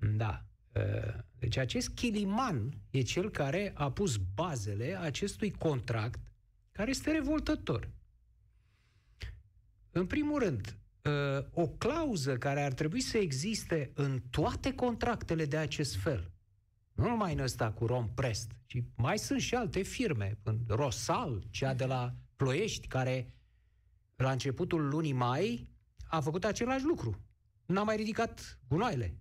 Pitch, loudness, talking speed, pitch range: 130 Hz, -34 LUFS, 125 wpm, 110-170 Hz